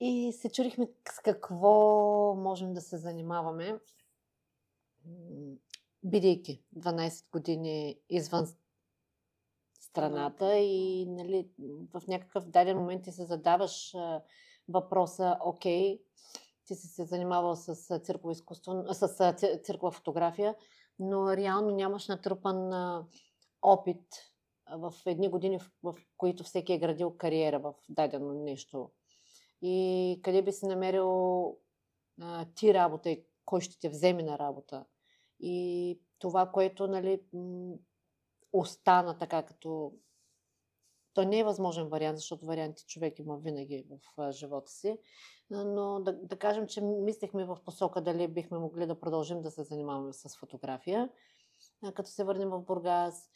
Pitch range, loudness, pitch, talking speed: 165-195 Hz, -32 LUFS, 180 Hz, 125 wpm